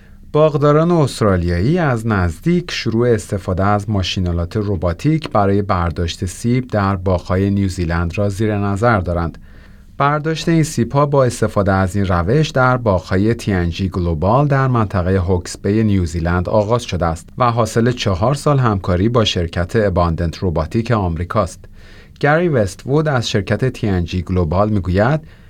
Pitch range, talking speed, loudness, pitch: 90-120 Hz, 135 wpm, -17 LUFS, 105 Hz